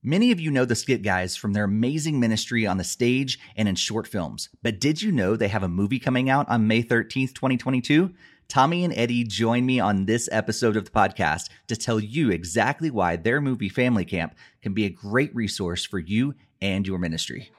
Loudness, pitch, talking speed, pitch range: -24 LUFS, 115 Hz, 210 wpm, 100-130 Hz